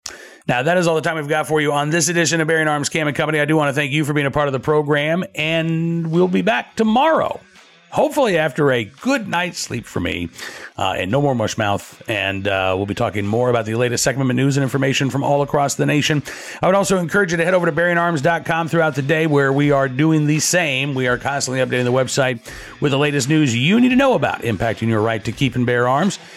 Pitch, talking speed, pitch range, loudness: 150 Hz, 255 wpm, 130-165 Hz, -18 LUFS